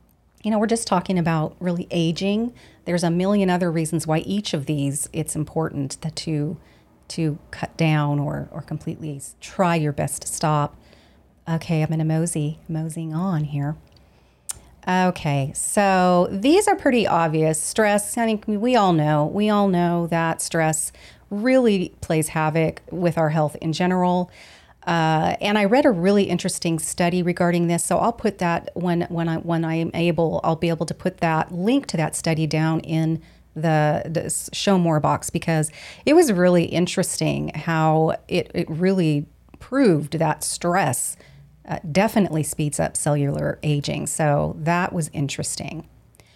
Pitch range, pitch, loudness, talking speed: 155-180 Hz, 165 Hz, -22 LUFS, 160 wpm